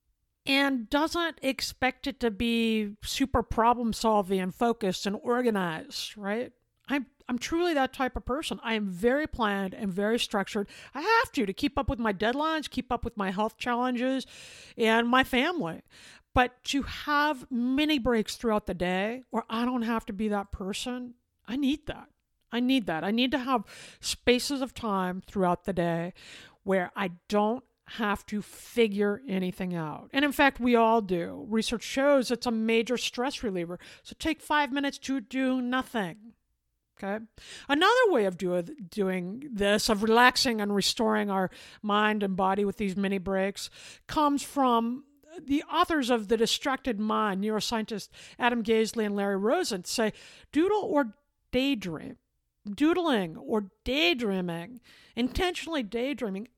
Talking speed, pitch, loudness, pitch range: 155 wpm, 235 Hz, -28 LUFS, 205-265 Hz